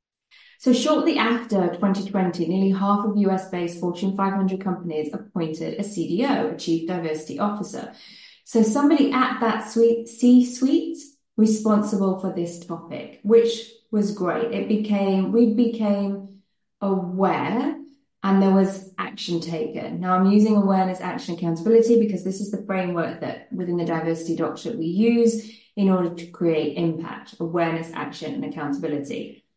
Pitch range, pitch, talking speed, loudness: 175-225 Hz, 195 Hz, 140 wpm, -22 LUFS